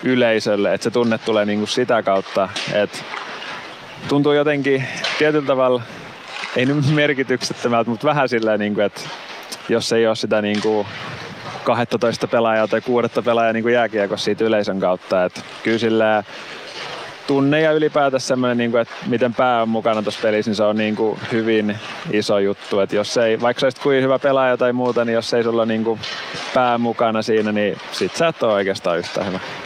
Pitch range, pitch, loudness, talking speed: 110-130 Hz, 115 Hz, -19 LUFS, 175 wpm